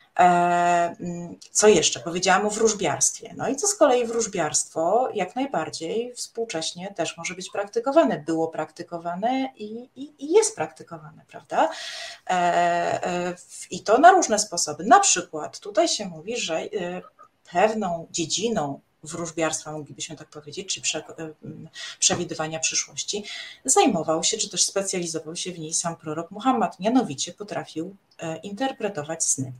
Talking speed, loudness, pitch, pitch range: 125 wpm, -23 LUFS, 175 Hz, 160-225 Hz